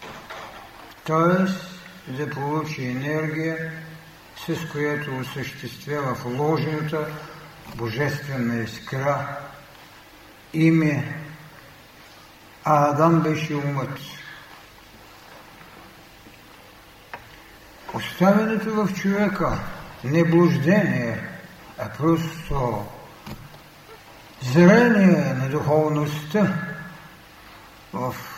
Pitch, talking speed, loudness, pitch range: 155 Hz, 60 wpm, -22 LUFS, 140-165 Hz